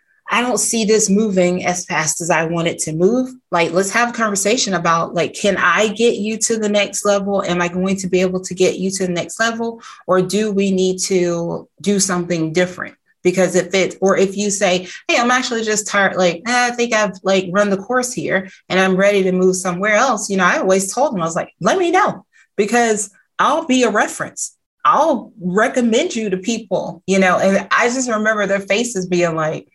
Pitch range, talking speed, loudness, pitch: 180-220 Hz, 220 wpm, -17 LUFS, 195 Hz